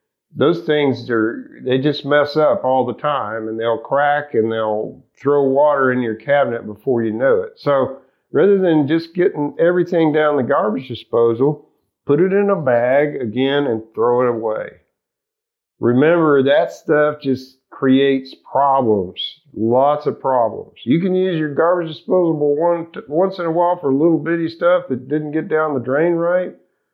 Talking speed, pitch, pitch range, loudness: 165 wpm, 145 Hz, 130-170 Hz, -17 LUFS